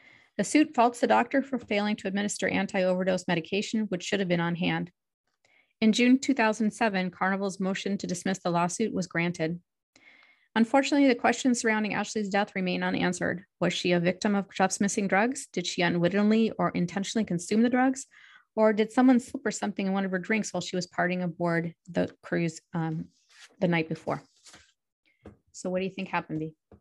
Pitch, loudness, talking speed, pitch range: 195 Hz, -27 LUFS, 185 wpm, 175-220 Hz